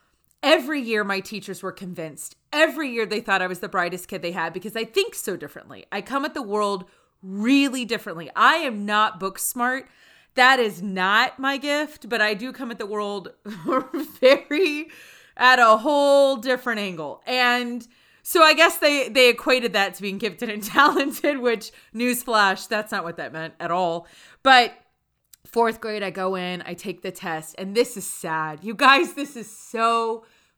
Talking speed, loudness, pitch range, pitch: 185 wpm, -21 LUFS, 195-265 Hz, 225 Hz